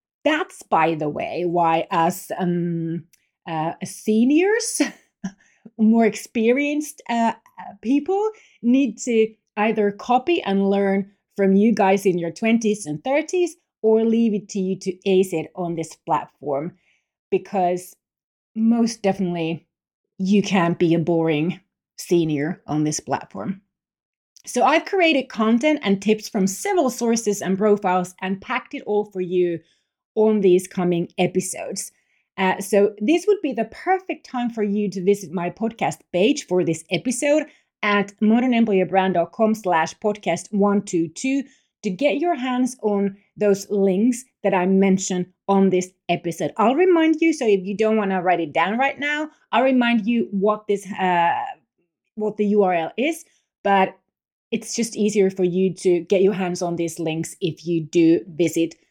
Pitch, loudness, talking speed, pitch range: 200 Hz, -21 LUFS, 150 wpm, 180-230 Hz